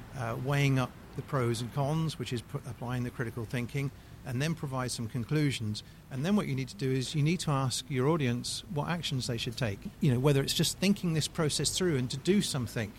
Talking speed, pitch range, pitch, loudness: 235 wpm, 125-150 Hz, 135 Hz, -31 LUFS